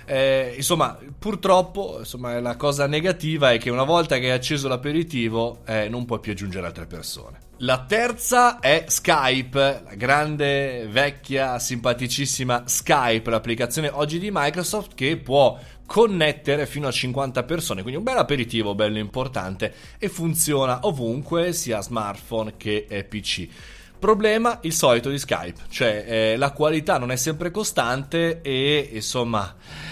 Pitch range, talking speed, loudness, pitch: 115-155 Hz, 140 wpm, -22 LUFS, 135 Hz